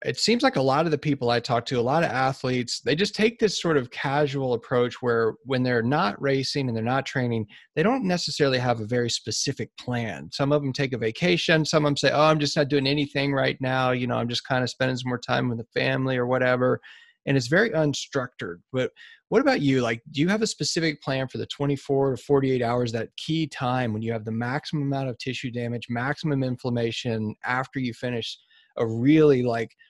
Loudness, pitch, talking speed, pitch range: -25 LUFS, 130 Hz, 230 wpm, 120-150 Hz